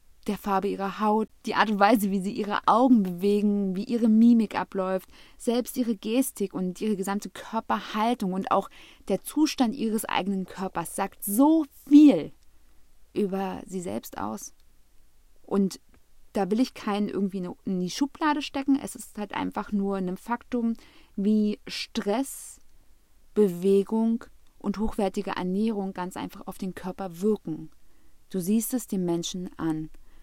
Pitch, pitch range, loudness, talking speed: 205 Hz, 195-235 Hz, -26 LUFS, 145 wpm